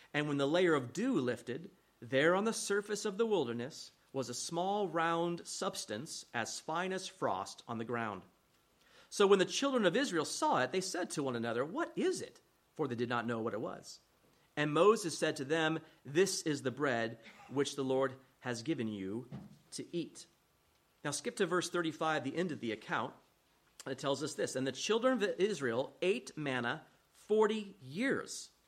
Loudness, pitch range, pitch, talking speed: -35 LUFS, 135-195 Hz, 160 Hz, 190 wpm